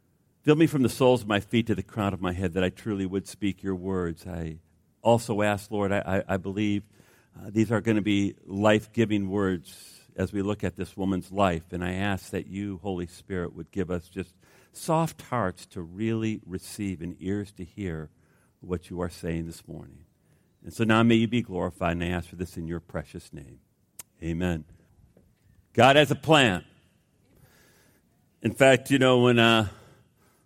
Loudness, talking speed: -26 LUFS, 195 wpm